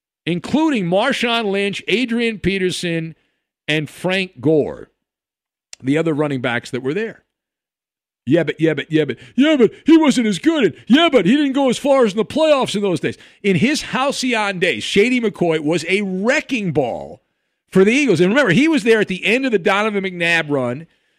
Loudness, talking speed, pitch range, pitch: -17 LUFS, 195 wpm, 165-250 Hz, 195 Hz